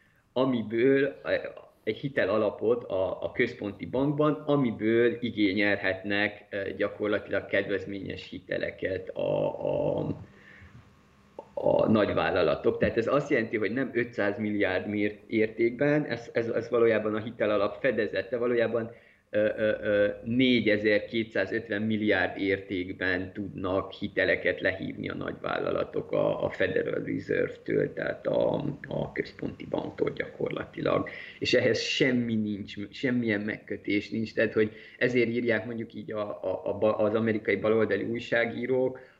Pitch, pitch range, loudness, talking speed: 115 Hz, 105-130 Hz, -28 LUFS, 105 wpm